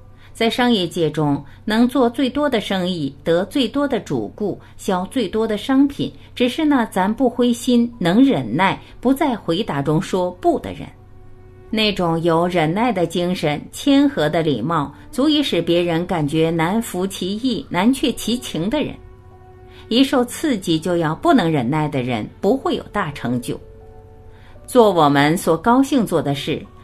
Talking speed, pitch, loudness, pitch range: 225 characters per minute, 180 Hz, -19 LUFS, 150-245 Hz